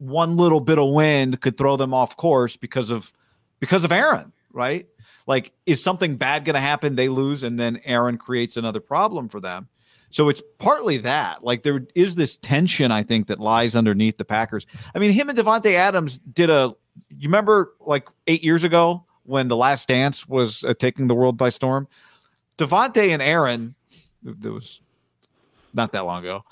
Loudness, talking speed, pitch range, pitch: -20 LUFS, 185 wpm, 120-165 Hz, 135 Hz